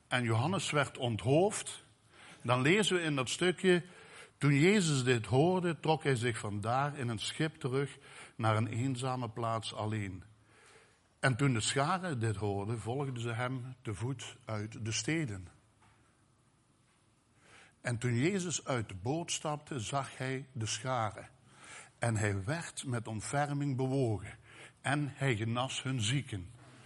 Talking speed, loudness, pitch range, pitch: 140 wpm, -34 LUFS, 115-145 Hz, 125 Hz